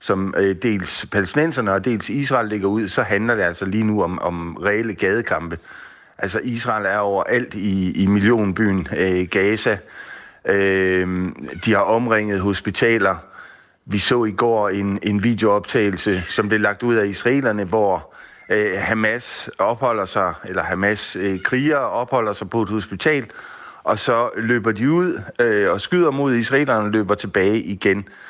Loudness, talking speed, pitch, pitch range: -19 LUFS, 145 wpm, 105 Hz, 95-115 Hz